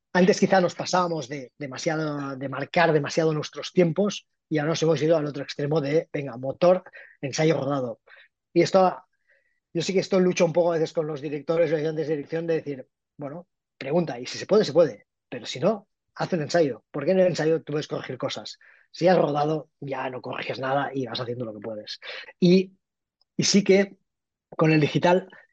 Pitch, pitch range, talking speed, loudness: 160 Hz, 145-180 Hz, 200 wpm, -24 LUFS